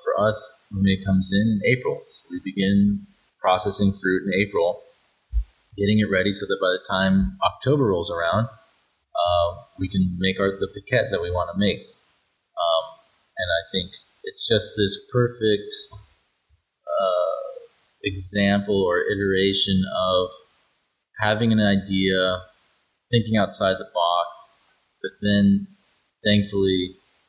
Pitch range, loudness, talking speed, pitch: 95-110 Hz, -22 LUFS, 135 wpm, 100 Hz